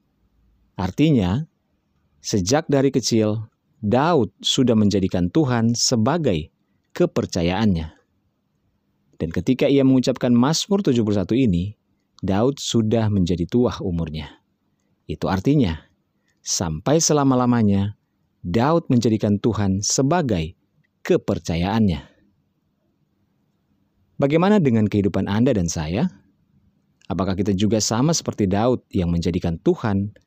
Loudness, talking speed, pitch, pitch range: -20 LUFS, 90 wpm, 105 Hz, 95-130 Hz